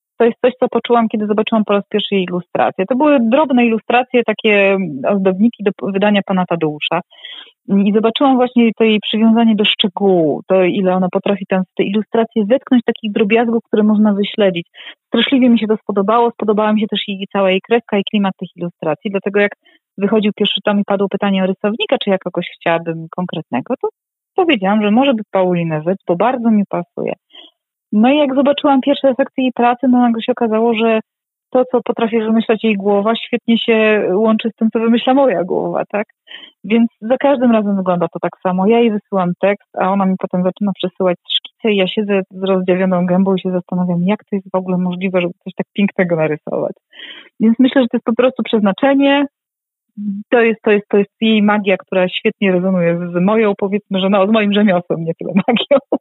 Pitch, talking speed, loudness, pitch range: 210 Hz, 200 wpm, -15 LUFS, 190-235 Hz